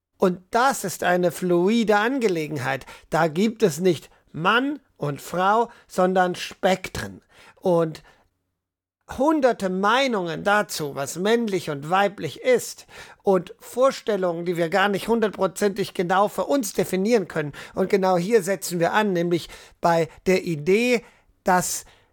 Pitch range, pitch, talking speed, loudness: 170-210 Hz, 190 Hz, 125 wpm, -23 LUFS